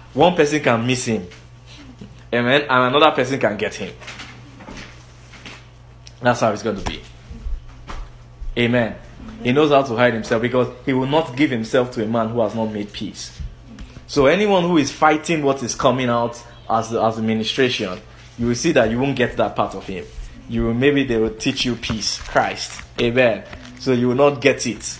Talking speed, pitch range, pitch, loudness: 185 wpm, 110-130 Hz, 120 Hz, -19 LUFS